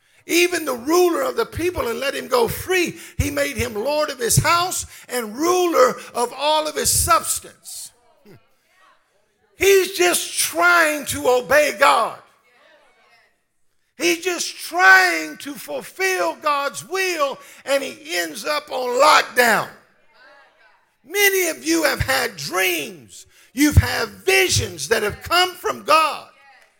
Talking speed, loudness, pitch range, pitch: 130 wpm, -18 LUFS, 285-360 Hz, 330 Hz